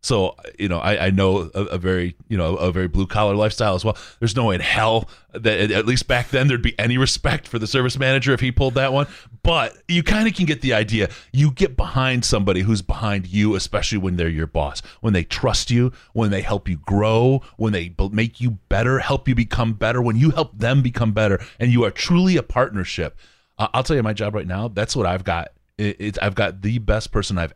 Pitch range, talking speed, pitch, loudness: 100-125 Hz, 235 wpm, 110 Hz, -20 LUFS